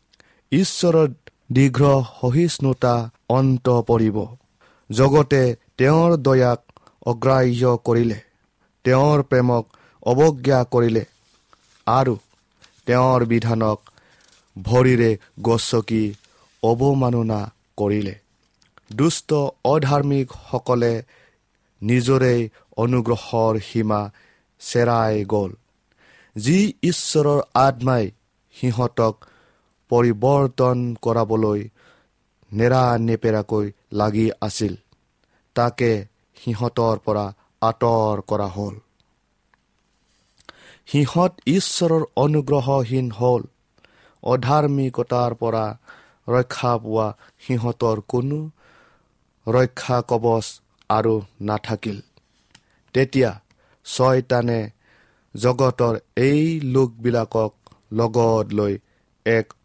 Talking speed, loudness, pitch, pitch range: 65 wpm, -20 LUFS, 120 Hz, 110-130 Hz